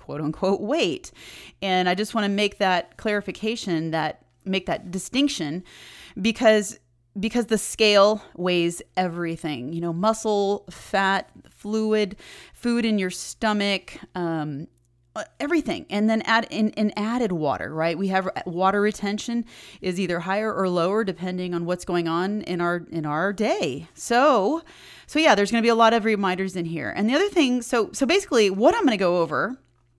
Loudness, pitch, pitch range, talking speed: -23 LUFS, 195 Hz, 175-220 Hz, 170 wpm